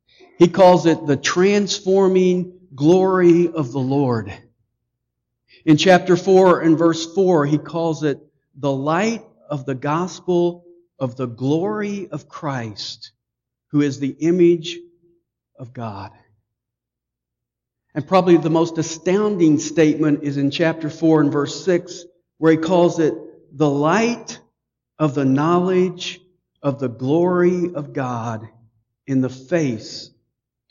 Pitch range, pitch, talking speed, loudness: 135-175 Hz, 155 Hz, 125 wpm, -18 LUFS